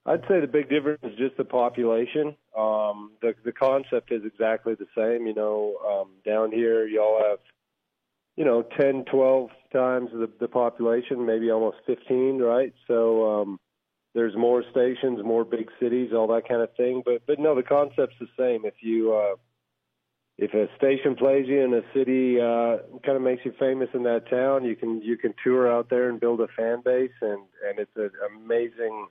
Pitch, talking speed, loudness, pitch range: 120 Hz, 195 wpm, -25 LUFS, 115-135 Hz